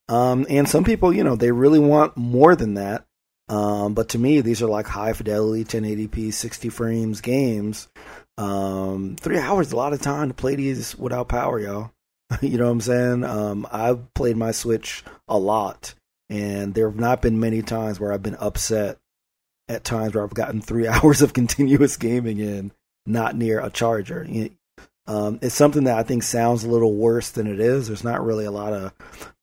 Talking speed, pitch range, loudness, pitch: 200 wpm, 105-125 Hz, -21 LUFS, 115 Hz